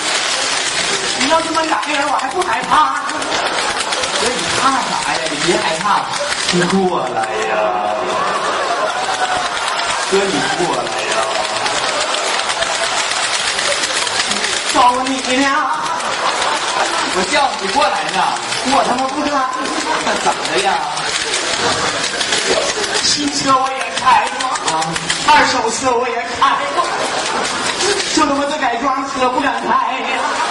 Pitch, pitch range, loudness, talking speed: 260 Hz, 230-285 Hz, -15 LUFS, 140 characters per minute